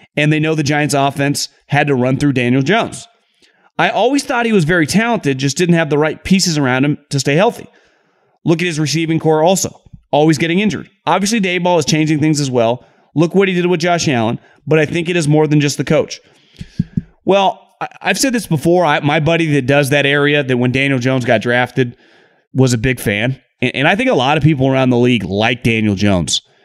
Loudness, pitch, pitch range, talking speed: -14 LUFS, 150 Hz, 130-175 Hz, 225 wpm